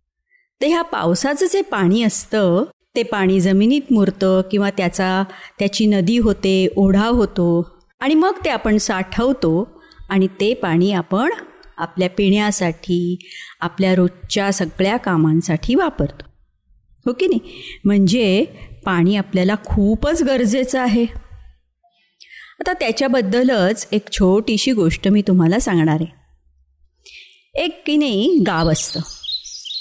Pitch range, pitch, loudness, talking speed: 180-240 Hz, 200 Hz, -17 LUFS, 115 wpm